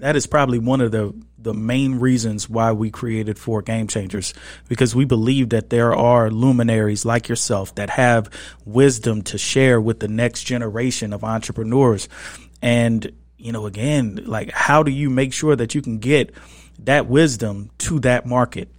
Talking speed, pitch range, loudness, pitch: 170 wpm, 110-130 Hz, -19 LUFS, 115 Hz